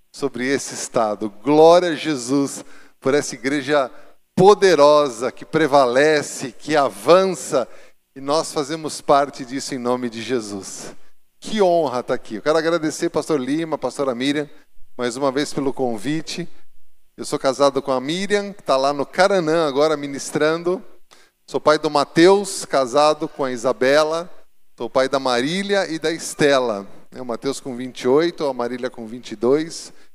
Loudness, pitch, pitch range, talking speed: -19 LUFS, 145 Hz, 130-160 Hz, 150 wpm